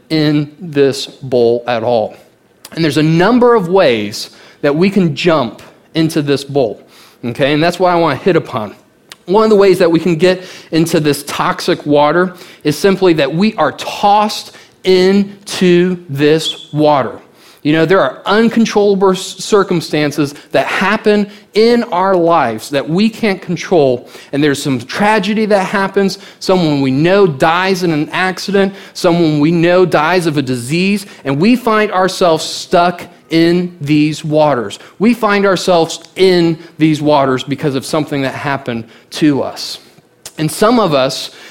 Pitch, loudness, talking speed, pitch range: 170 Hz, -13 LUFS, 155 wpm, 150-195 Hz